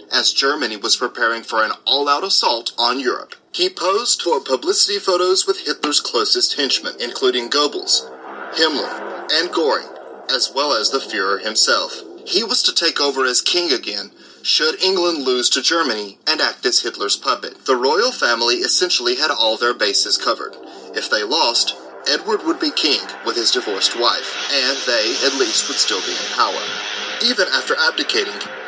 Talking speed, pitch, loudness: 165 wpm, 360 Hz, -17 LUFS